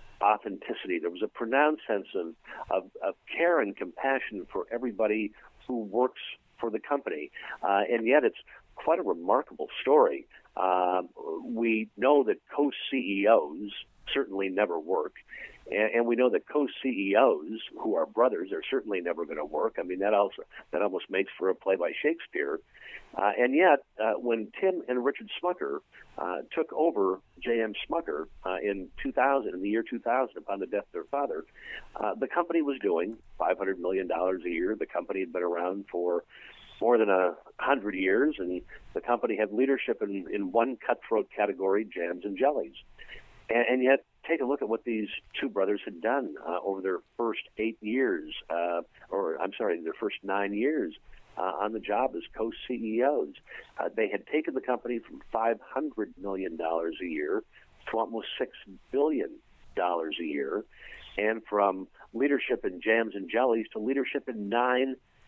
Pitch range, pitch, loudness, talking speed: 100-140 Hz, 115 Hz, -29 LUFS, 175 wpm